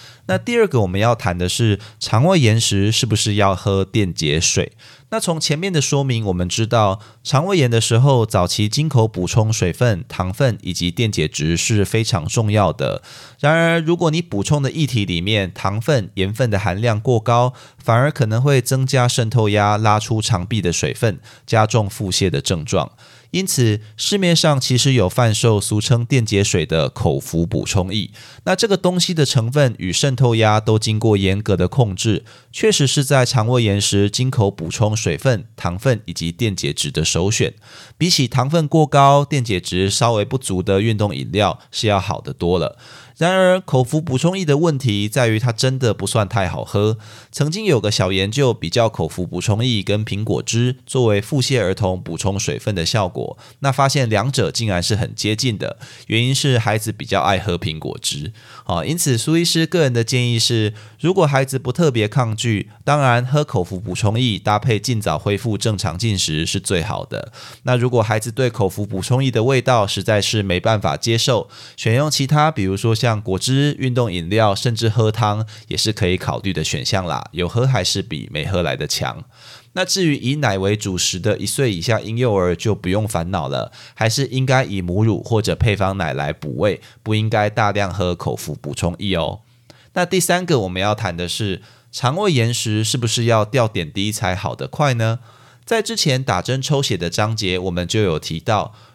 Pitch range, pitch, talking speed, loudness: 100-130 Hz, 115 Hz, 280 characters per minute, -18 LUFS